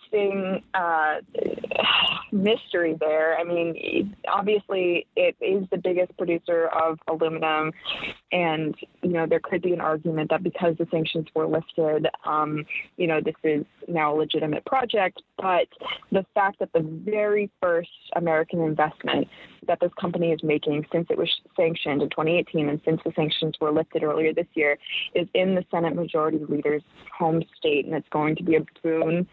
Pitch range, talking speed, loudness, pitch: 155-180 Hz, 165 wpm, -25 LUFS, 165 Hz